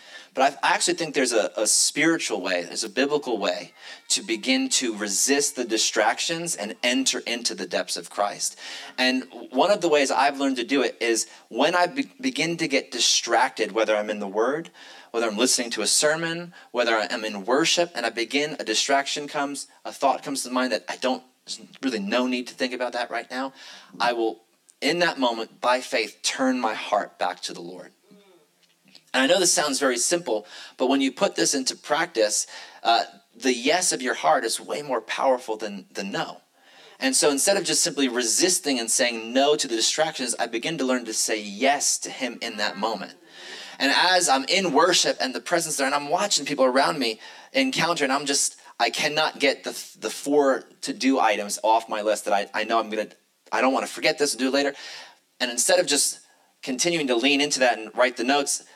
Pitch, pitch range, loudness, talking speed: 120 Hz, 90-140 Hz, -23 LUFS, 215 wpm